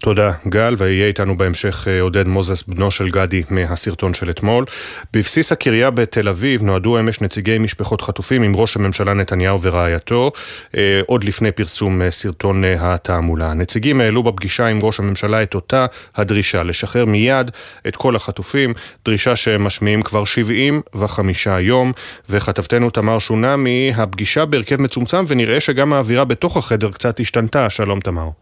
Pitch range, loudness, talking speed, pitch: 95-120 Hz, -16 LUFS, 140 wpm, 105 Hz